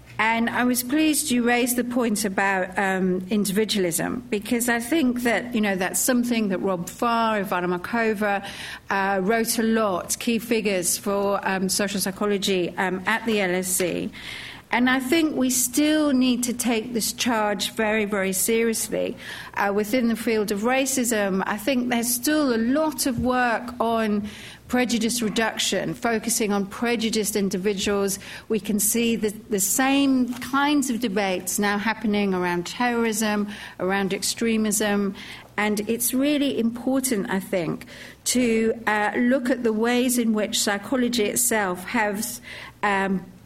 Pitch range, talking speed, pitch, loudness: 200-240 Hz, 145 wpm, 220 Hz, -23 LUFS